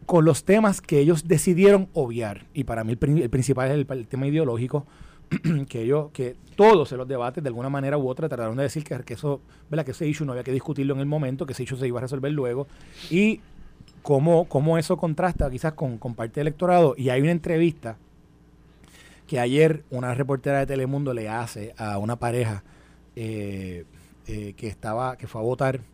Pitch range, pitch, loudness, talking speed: 120-155 Hz, 135 Hz, -24 LUFS, 210 wpm